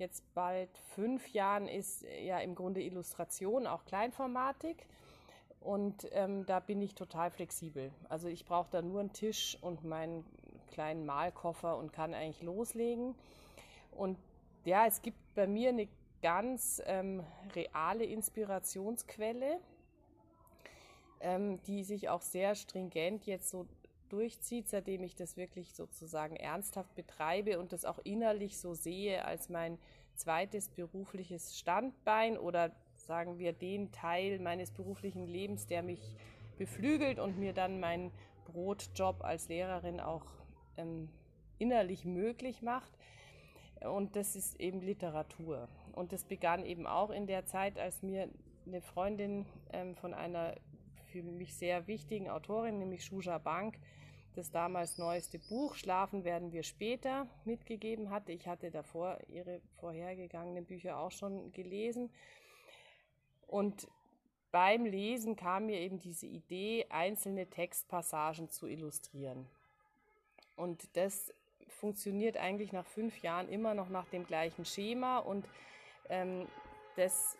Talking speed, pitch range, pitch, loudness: 130 wpm, 170-205 Hz, 185 Hz, -40 LUFS